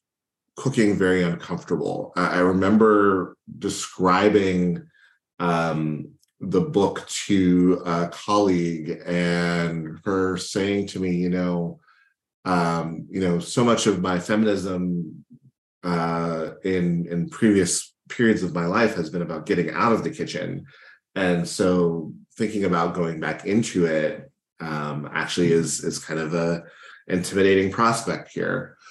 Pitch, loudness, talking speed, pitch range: 90 Hz, -23 LUFS, 125 wpm, 85-95 Hz